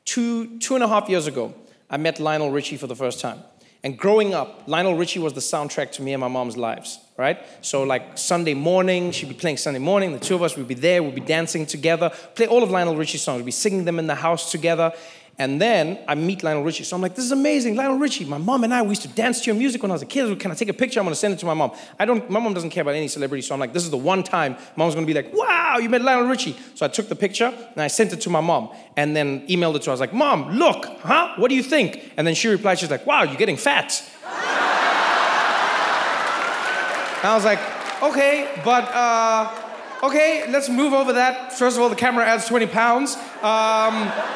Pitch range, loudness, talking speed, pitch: 160-235 Hz, -21 LUFS, 260 wpm, 190 Hz